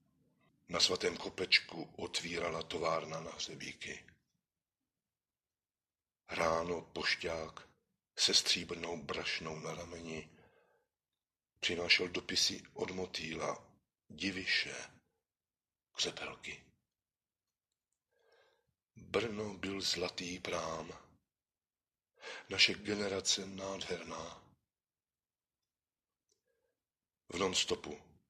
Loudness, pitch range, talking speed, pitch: -36 LUFS, 80-100 Hz, 65 wpm, 90 Hz